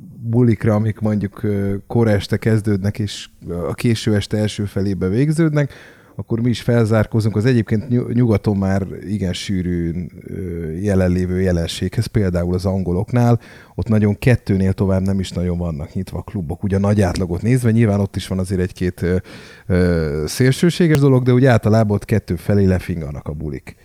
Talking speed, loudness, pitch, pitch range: 155 wpm, -18 LUFS, 100 Hz, 90-115 Hz